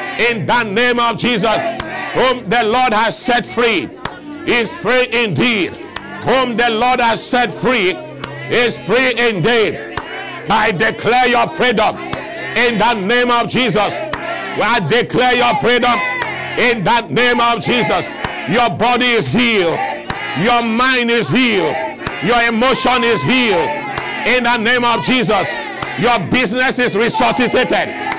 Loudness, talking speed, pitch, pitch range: -14 LUFS, 130 wpm, 240 Hz, 235-250 Hz